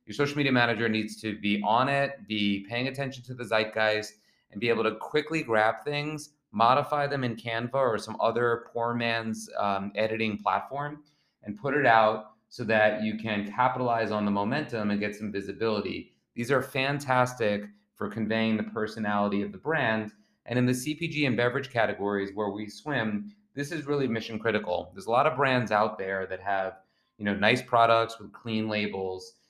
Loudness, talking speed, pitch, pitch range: -28 LUFS, 185 wpm, 110 Hz, 105-125 Hz